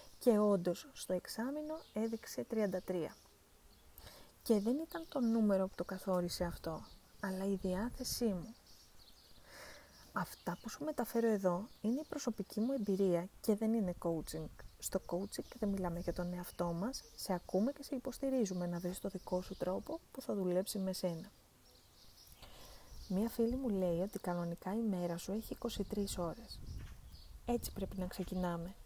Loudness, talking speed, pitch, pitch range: -39 LUFS, 155 wpm, 195 Hz, 180-230 Hz